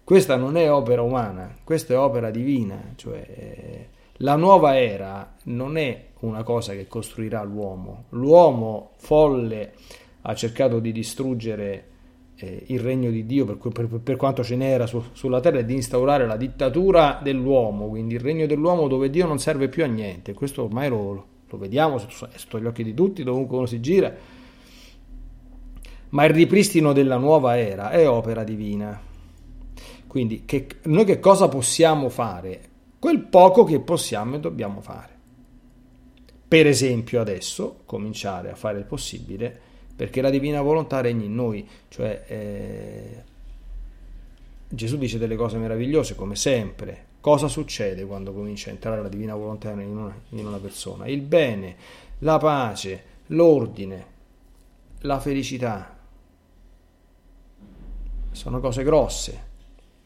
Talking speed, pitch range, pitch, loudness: 145 wpm, 105-140 Hz, 120 Hz, -22 LUFS